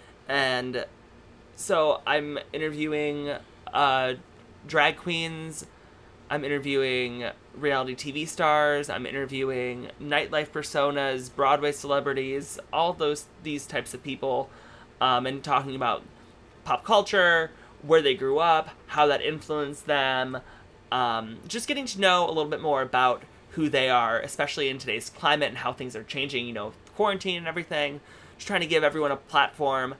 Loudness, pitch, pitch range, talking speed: -26 LUFS, 145 Hz, 130-155 Hz, 145 wpm